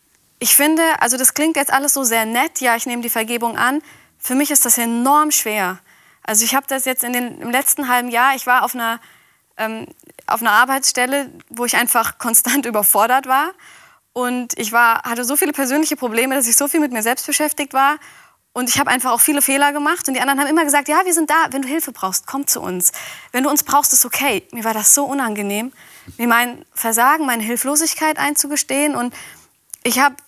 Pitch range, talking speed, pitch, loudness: 235-290 Hz, 215 wpm, 260 Hz, -16 LUFS